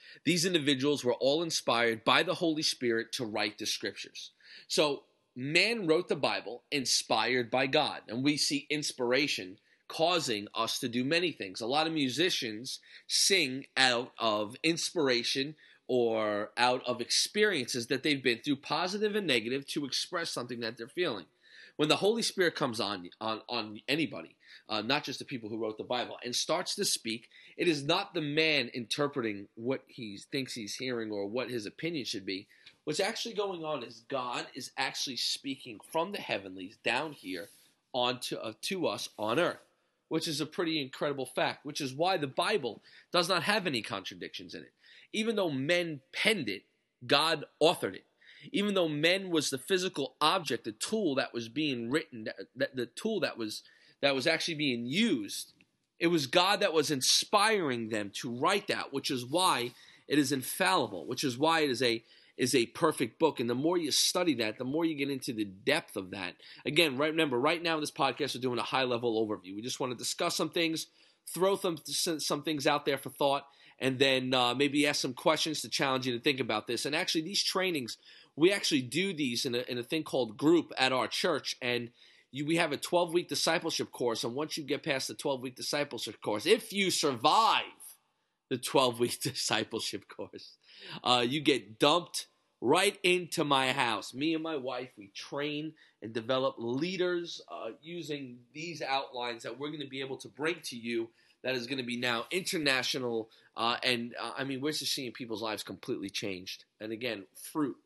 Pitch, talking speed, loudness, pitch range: 140 Hz, 190 wpm, -31 LUFS, 120-160 Hz